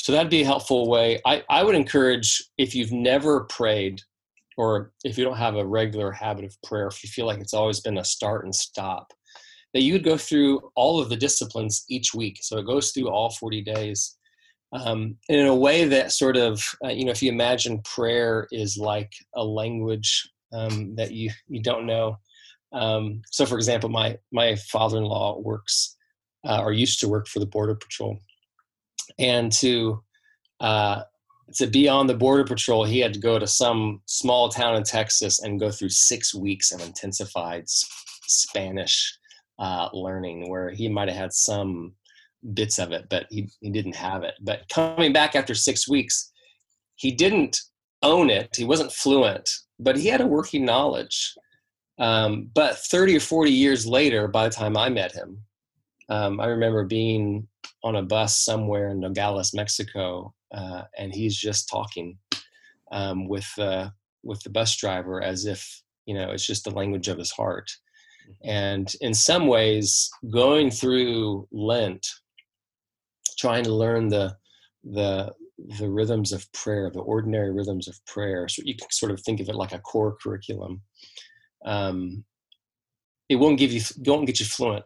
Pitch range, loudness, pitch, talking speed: 100-125 Hz, -23 LUFS, 110 Hz, 175 wpm